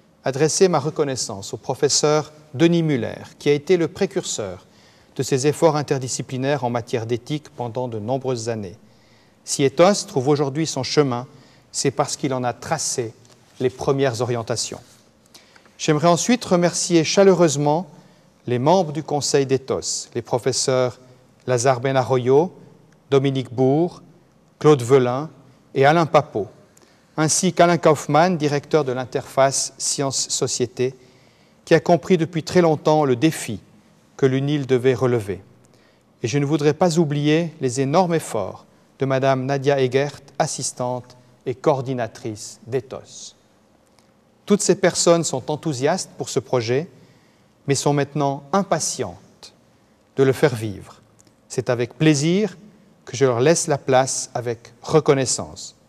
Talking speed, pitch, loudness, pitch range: 130 wpm, 140 Hz, -20 LUFS, 130-160 Hz